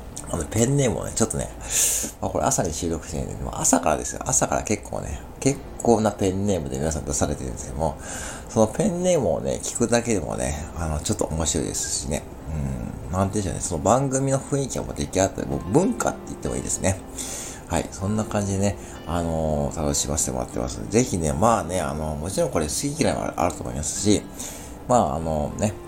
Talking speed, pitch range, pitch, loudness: 460 characters per minute, 75-105 Hz, 85 Hz, -24 LUFS